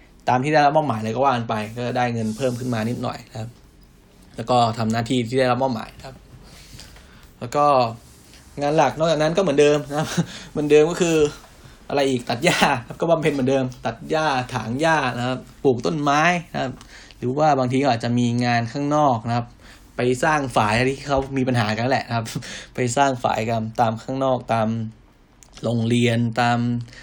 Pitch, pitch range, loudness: 125 Hz, 115-145 Hz, -21 LUFS